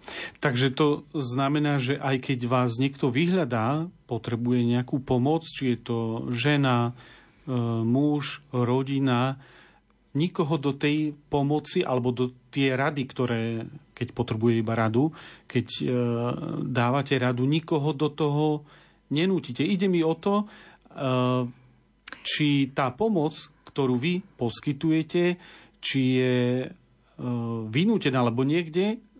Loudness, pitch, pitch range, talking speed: -26 LUFS, 135 Hz, 125-155 Hz, 110 wpm